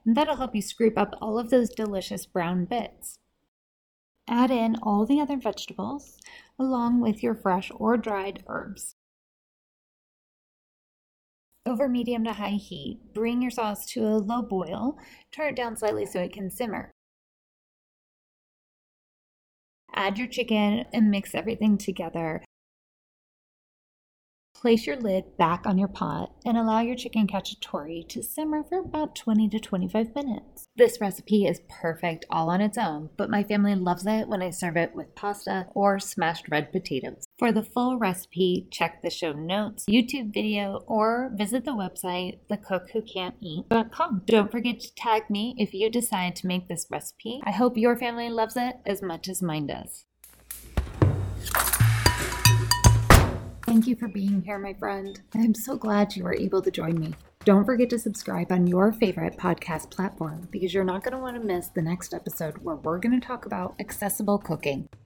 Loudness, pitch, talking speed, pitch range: -26 LUFS, 205 Hz, 165 wpm, 180-230 Hz